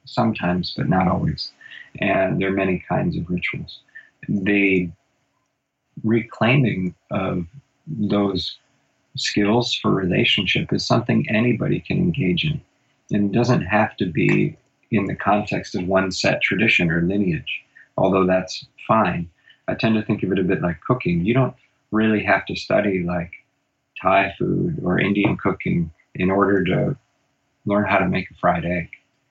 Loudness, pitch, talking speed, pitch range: -21 LUFS, 100 Hz, 150 wpm, 90-120 Hz